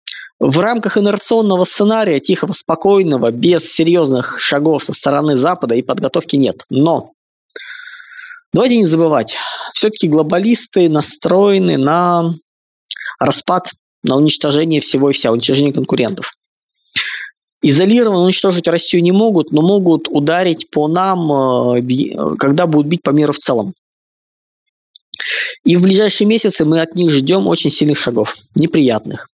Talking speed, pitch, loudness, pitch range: 125 wpm, 170 Hz, -13 LUFS, 150-205 Hz